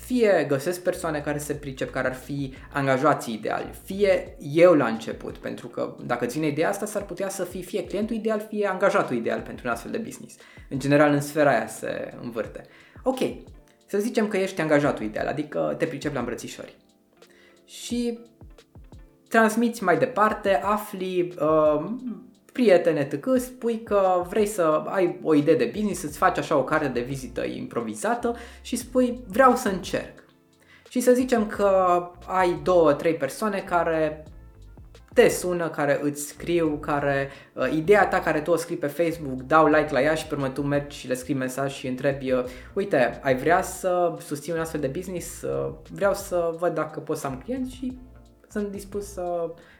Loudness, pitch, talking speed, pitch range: -24 LUFS, 175 Hz, 175 wpm, 145-205 Hz